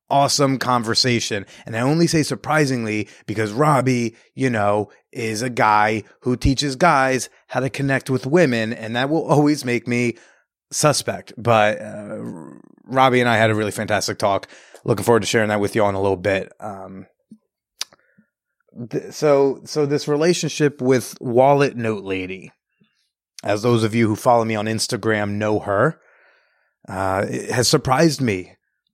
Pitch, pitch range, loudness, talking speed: 120 Hz, 105-140 Hz, -19 LUFS, 160 wpm